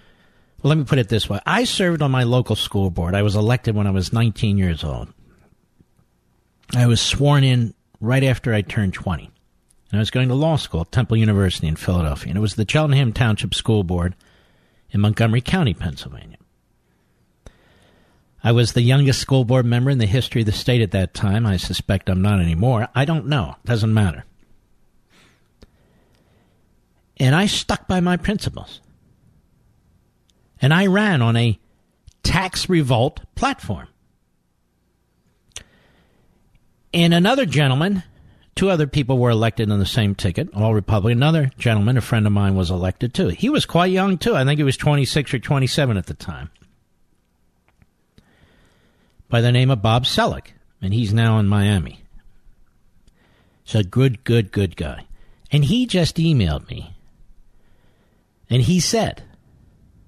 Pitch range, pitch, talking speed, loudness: 95-135 Hz, 115 Hz, 160 wpm, -19 LUFS